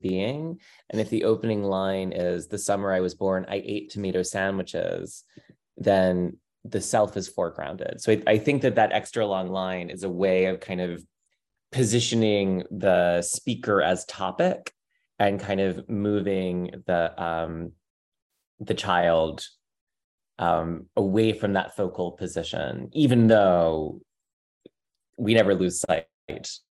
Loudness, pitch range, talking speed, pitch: -25 LUFS, 90-105 Hz, 135 wpm, 95 Hz